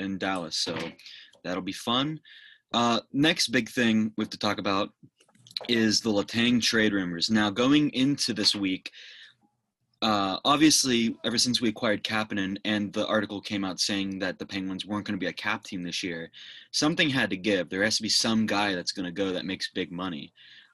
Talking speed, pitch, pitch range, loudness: 195 wpm, 105 Hz, 100-120 Hz, -26 LUFS